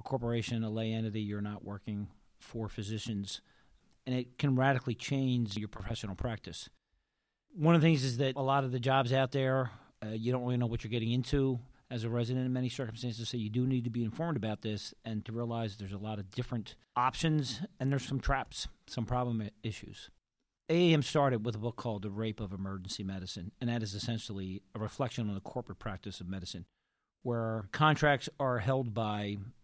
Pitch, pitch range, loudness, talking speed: 115 Hz, 105-130 Hz, -34 LUFS, 200 wpm